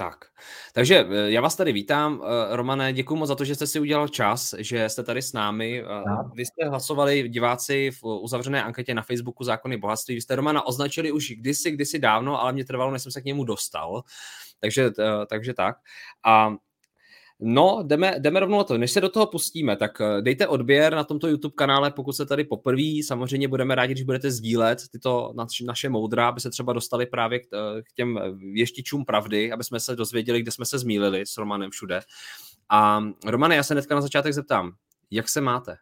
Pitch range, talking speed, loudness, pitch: 115-140 Hz, 190 wpm, -24 LUFS, 125 Hz